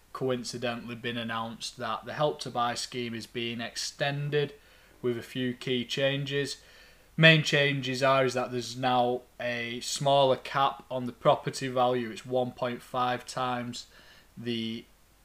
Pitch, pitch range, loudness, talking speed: 125 Hz, 120-135 Hz, -29 LUFS, 140 wpm